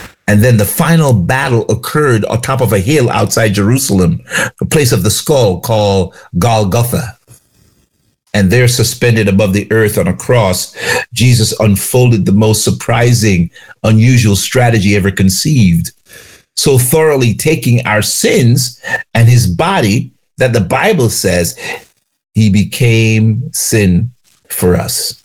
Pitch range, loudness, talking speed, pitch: 100-125 Hz, -11 LUFS, 130 wpm, 110 Hz